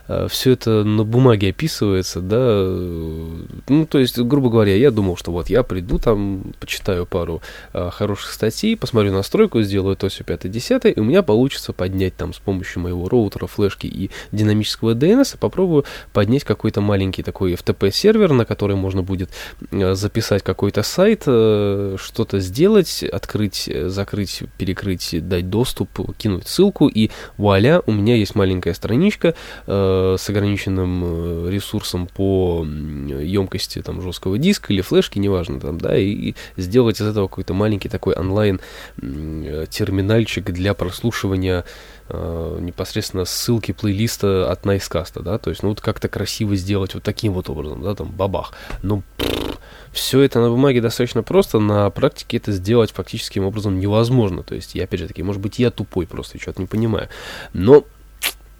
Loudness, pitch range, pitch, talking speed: -19 LUFS, 95-115 Hz, 100 Hz, 155 wpm